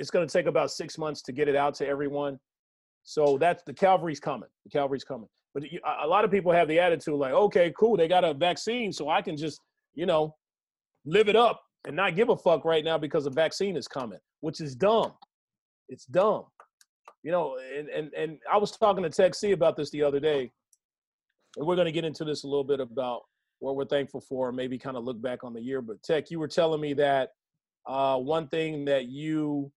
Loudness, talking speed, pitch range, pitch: -27 LUFS, 230 wpm, 140-175 Hz, 155 Hz